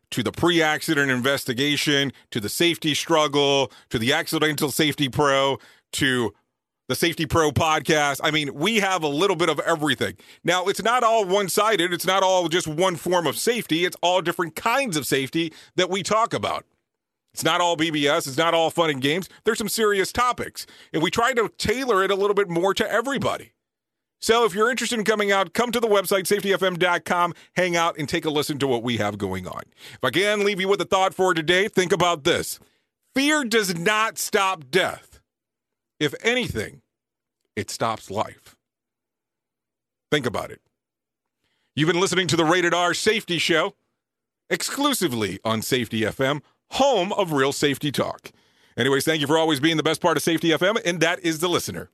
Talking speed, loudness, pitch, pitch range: 190 wpm, -22 LUFS, 170 Hz, 150-195 Hz